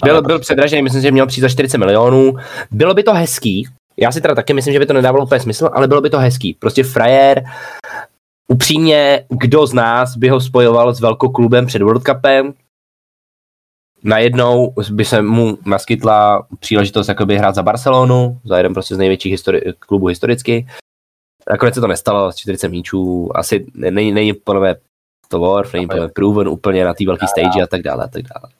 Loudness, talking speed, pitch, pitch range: -13 LUFS, 190 wpm, 115 Hz, 100-130 Hz